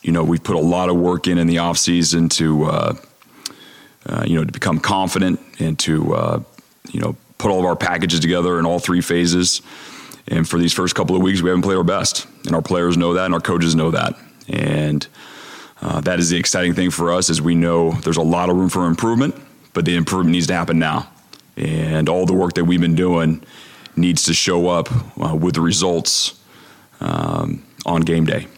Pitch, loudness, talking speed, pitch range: 85 Hz, -18 LUFS, 215 wpm, 85-90 Hz